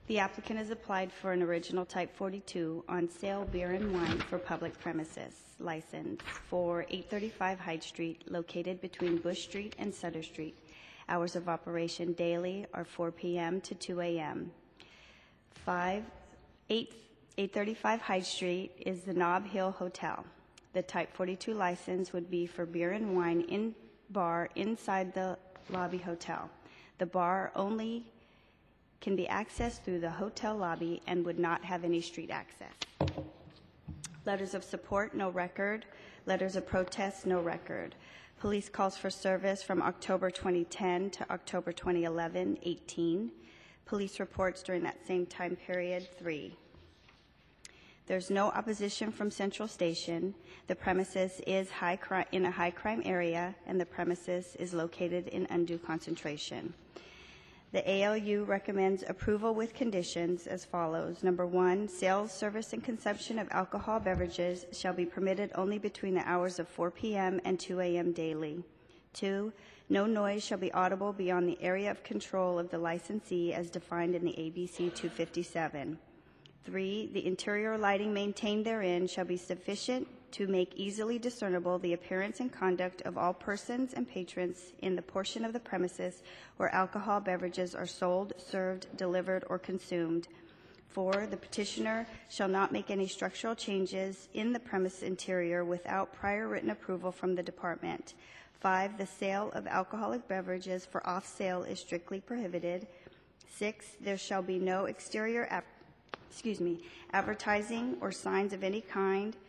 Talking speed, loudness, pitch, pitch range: 150 wpm, -36 LUFS, 185 Hz, 175-200 Hz